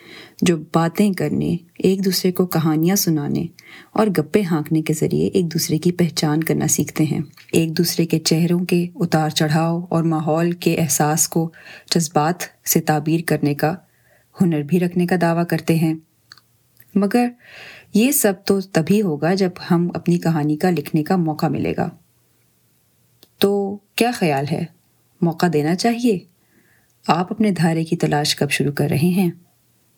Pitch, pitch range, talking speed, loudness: 170 Hz, 155-185 Hz, 155 wpm, -19 LUFS